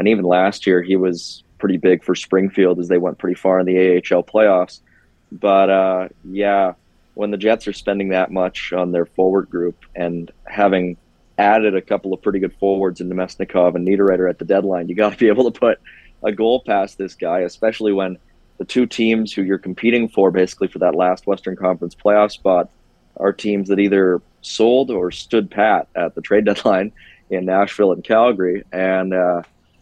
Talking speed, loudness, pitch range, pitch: 195 wpm, -17 LUFS, 90-100 Hz, 95 Hz